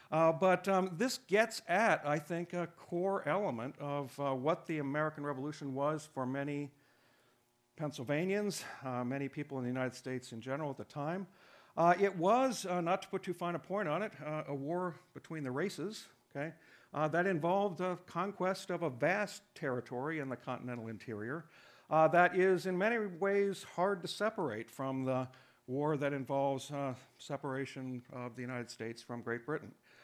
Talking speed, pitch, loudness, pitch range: 180 wpm, 150 Hz, -36 LUFS, 130-180 Hz